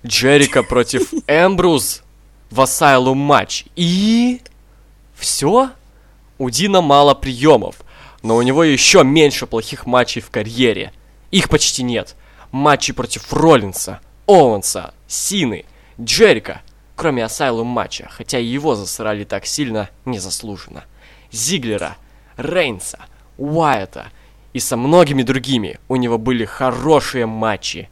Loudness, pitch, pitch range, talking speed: -15 LUFS, 130 Hz, 115-150 Hz, 110 wpm